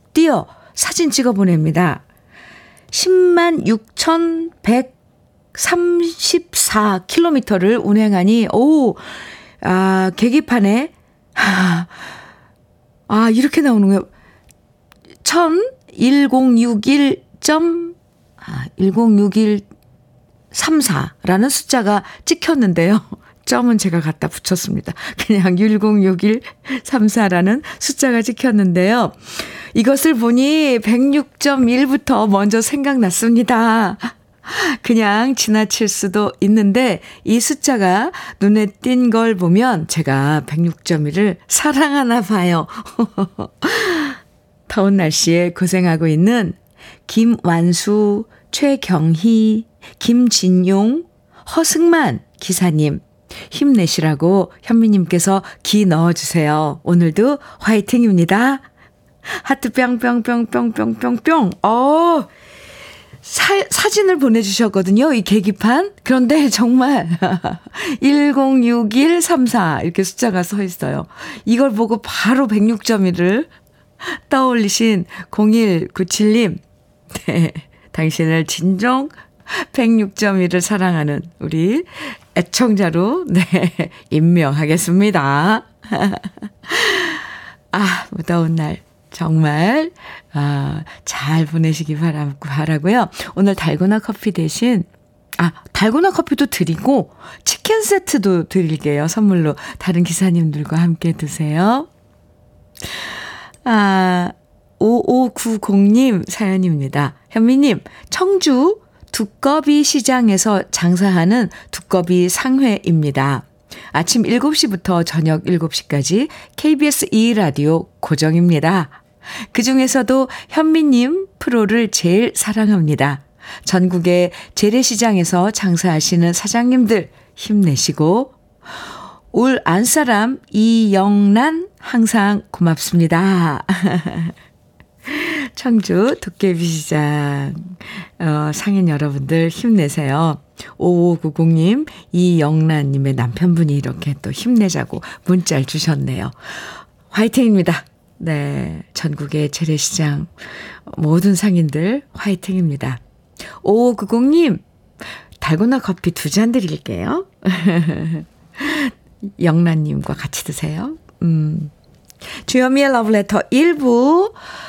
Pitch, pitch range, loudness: 205 Hz, 170-250 Hz, -15 LUFS